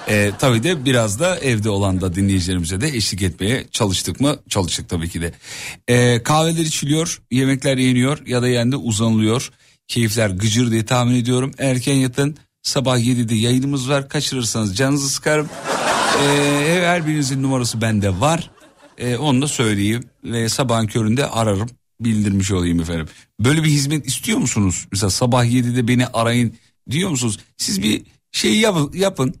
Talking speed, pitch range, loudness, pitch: 155 wpm, 110-140 Hz, -18 LUFS, 125 Hz